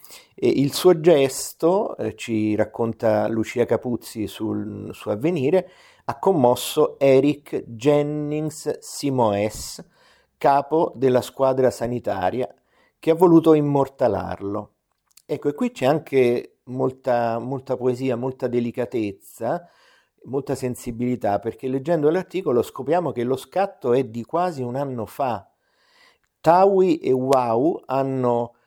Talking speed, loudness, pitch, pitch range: 110 wpm, -22 LUFS, 130 Hz, 120-150 Hz